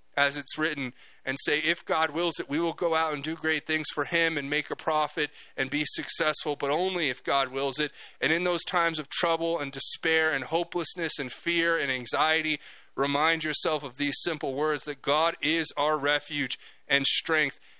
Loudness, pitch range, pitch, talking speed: -27 LUFS, 145-165 Hz, 155 Hz, 200 wpm